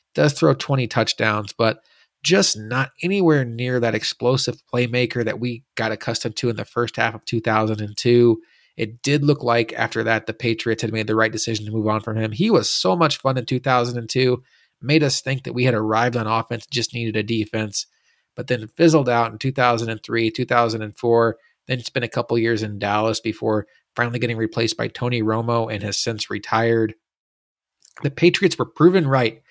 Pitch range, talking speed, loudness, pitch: 110-125 Hz, 185 wpm, -20 LUFS, 115 Hz